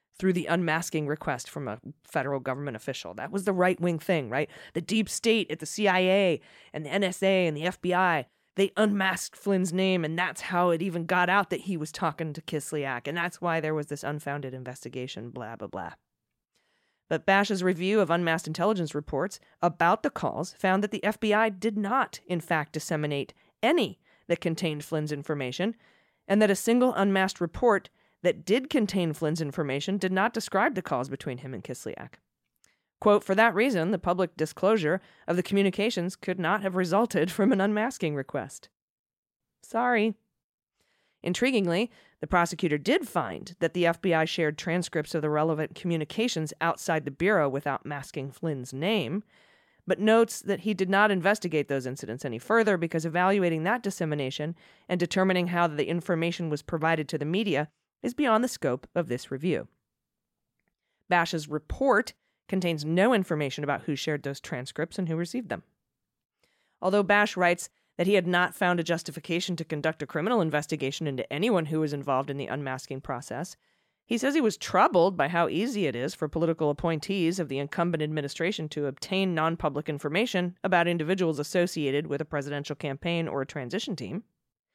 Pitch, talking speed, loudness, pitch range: 170 Hz, 170 wpm, -28 LUFS, 150-195 Hz